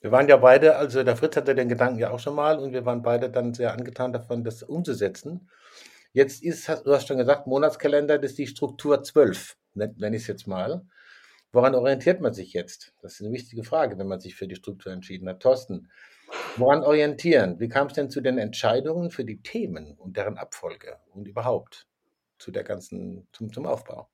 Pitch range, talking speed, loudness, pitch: 120-150 Hz, 205 wpm, -24 LUFS, 135 Hz